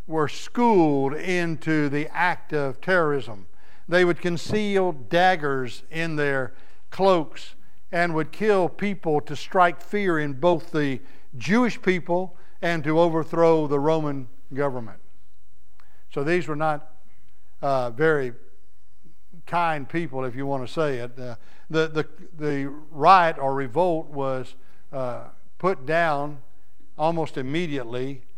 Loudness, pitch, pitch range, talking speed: -24 LUFS, 150 Hz, 135-170 Hz, 125 wpm